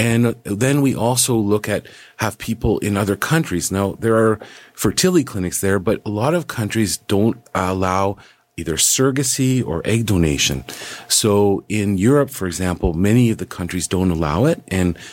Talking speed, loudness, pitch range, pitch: 165 wpm, -18 LUFS, 95-115 Hz, 105 Hz